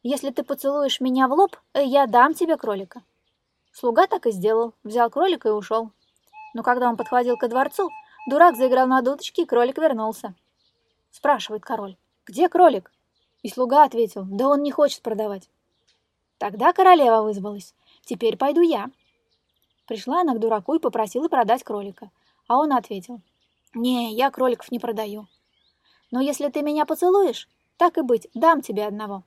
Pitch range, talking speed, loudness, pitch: 225-300 Hz, 155 wpm, -21 LUFS, 255 Hz